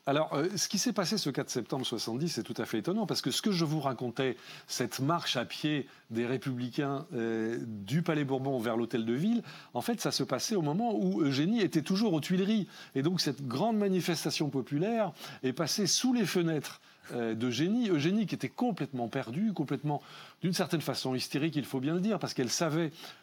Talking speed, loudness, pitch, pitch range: 205 wpm, -32 LUFS, 150 Hz, 130-185 Hz